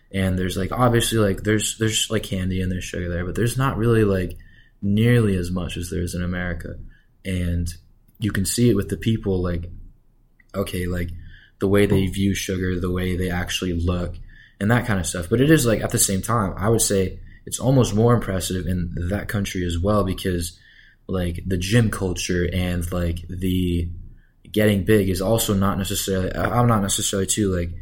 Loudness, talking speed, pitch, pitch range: -22 LUFS, 195 wpm, 95 Hz, 90-105 Hz